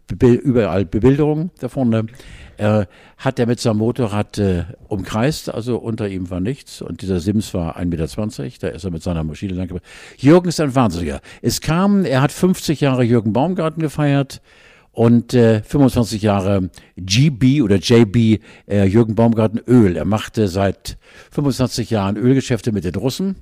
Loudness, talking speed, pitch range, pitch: -17 LUFS, 155 wpm, 100-130 Hz, 115 Hz